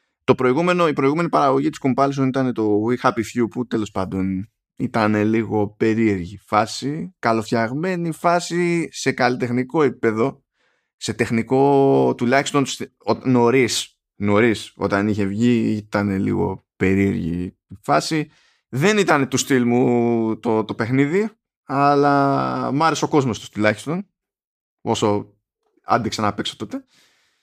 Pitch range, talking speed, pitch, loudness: 105-140 Hz, 120 wpm, 120 Hz, -20 LUFS